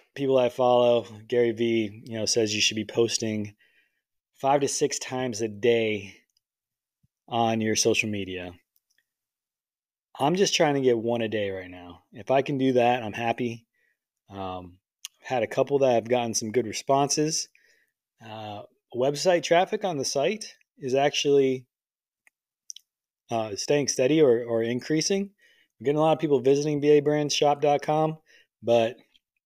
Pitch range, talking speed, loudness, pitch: 110-145 Hz, 145 wpm, -25 LUFS, 125 Hz